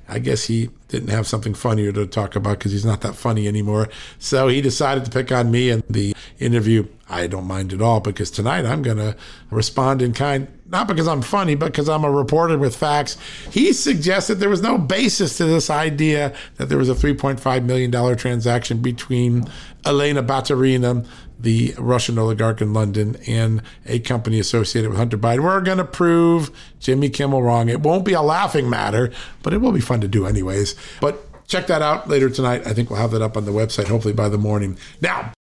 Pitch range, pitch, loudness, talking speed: 110-145 Hz, 125 Hz, -19 LUFS, 205 wpm